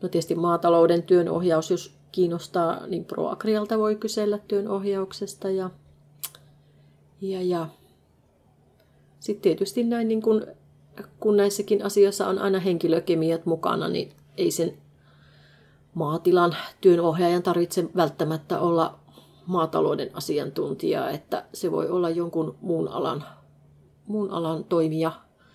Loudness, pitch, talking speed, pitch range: -25 LUFS, 175 Hz, 110 wpm, 165-200 Hz